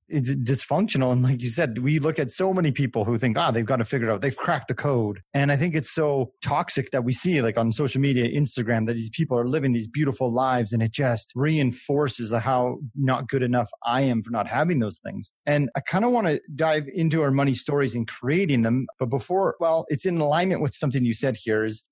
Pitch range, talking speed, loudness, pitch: 120-150 Hz, 245 wpm, -24 LUFS, 135 Hz